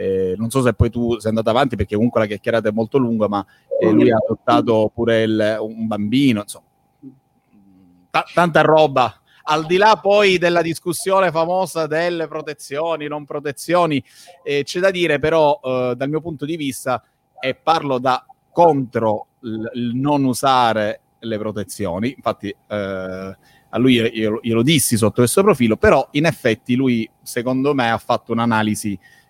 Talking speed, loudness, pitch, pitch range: 170 wpm, -18 LUFS, 130 Hz, 110-155 Hz